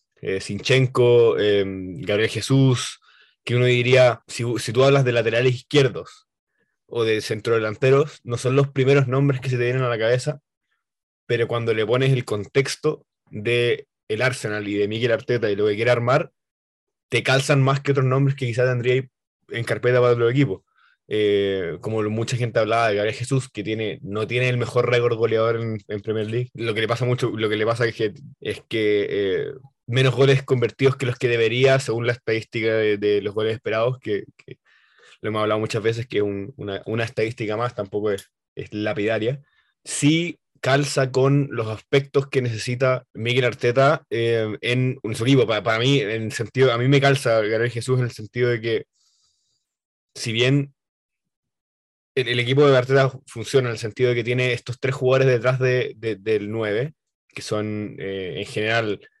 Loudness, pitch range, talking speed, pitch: -21 LUFS, 110-130 Hz, 185 wpm, 120 Hz